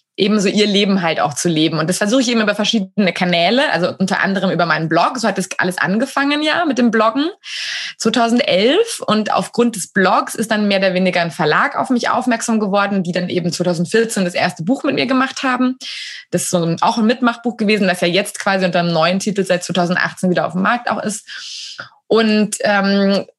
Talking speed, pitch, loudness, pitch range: 210 wpm, 205 Hz, -16 LUFS, 180-235 Hz